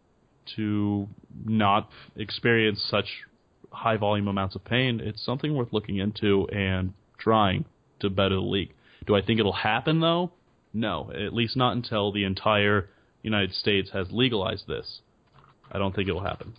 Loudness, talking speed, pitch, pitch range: -26 LUFS, 155 wpm, 105 Hz, 100-115 Hz